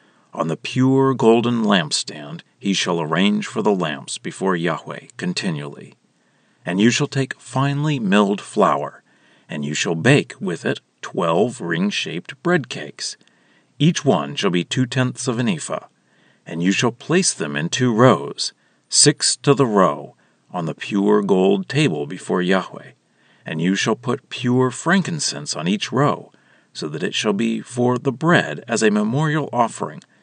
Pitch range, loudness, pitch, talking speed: 115-165 Hz, -19 LUFS, 135 Hz, 160 wpm